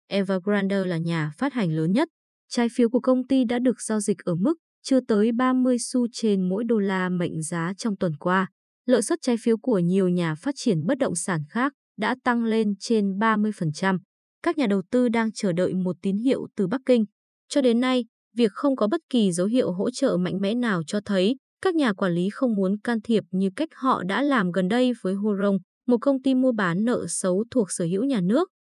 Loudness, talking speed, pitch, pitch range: -24 LUFS, 225 wpm, 220 Hz, 190-250 Hz